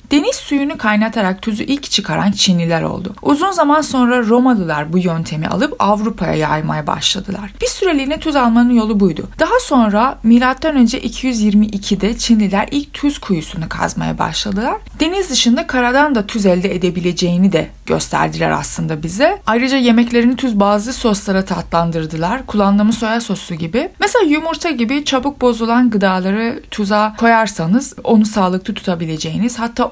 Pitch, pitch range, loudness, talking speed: 225 Hz, 195-260 Hz, -14 LUFS, 135 wpm